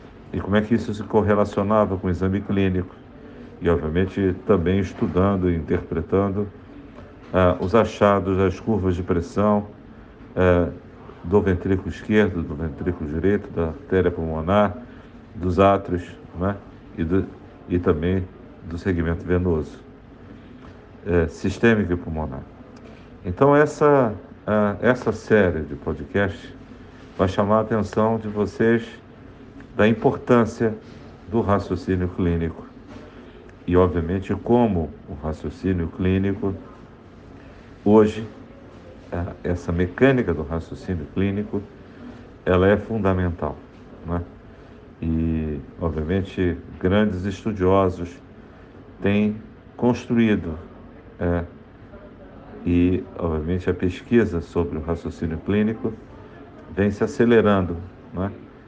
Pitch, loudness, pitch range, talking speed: 95 Hz, -22 LUFS, 85-105 Hz, 105 wpm